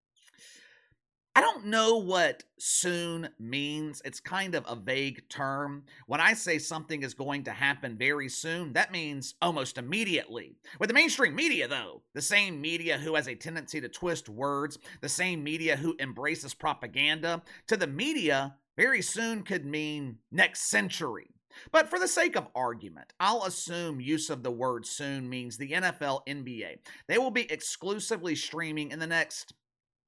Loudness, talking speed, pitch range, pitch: -29 LUFS, 160 wpm, 135-175 Hz, 155 Hz